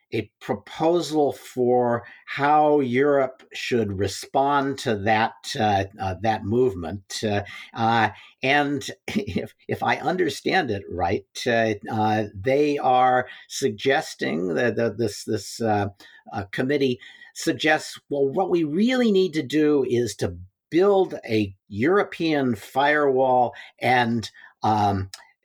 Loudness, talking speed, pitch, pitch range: -23 LUFS, 120 wpm, 125 Hz, 110-145 Hz